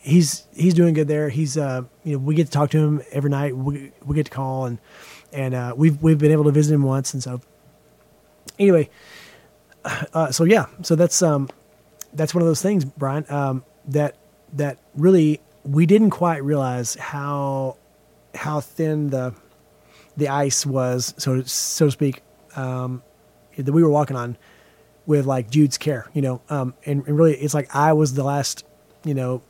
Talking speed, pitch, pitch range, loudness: 185 wpm, 145 Hz, 135-155 Hz, -20 LUFS